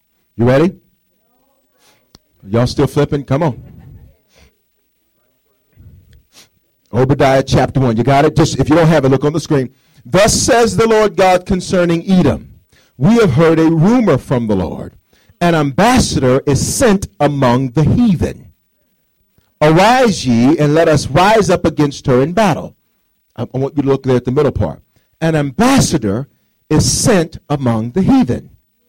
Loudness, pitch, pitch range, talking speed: -13 LUFS, 150 Hz, 130-180 Hz, 150 wpm